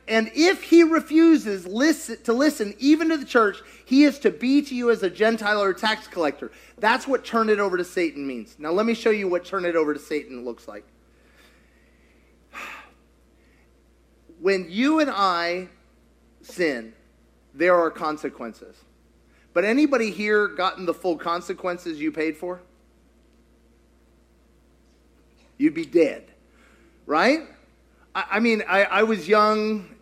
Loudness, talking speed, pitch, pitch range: -22 LUFS, 150 wpm, 195 Hz, 145-230 Hz